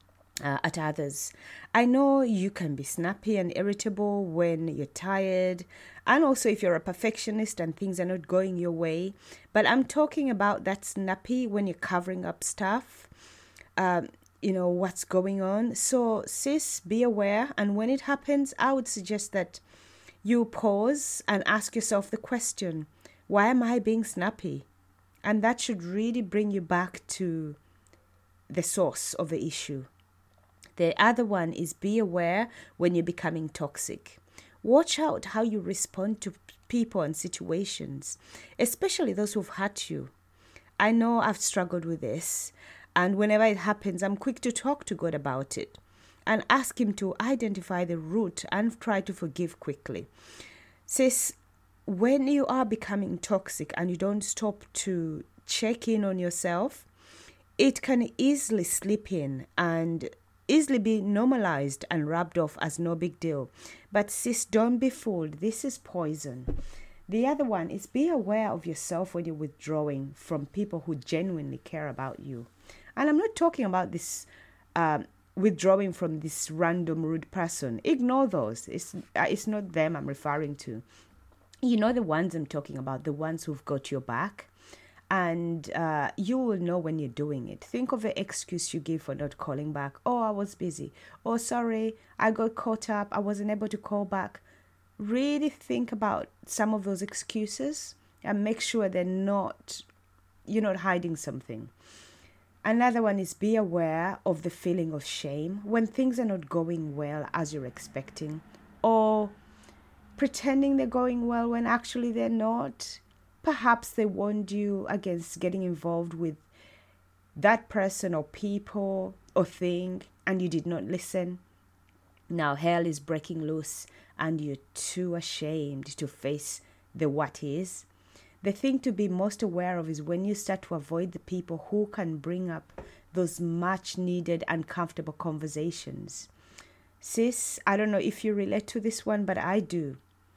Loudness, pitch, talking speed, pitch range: -29 LUFS, 185 Hz, 160 wpm, 155-215 Hz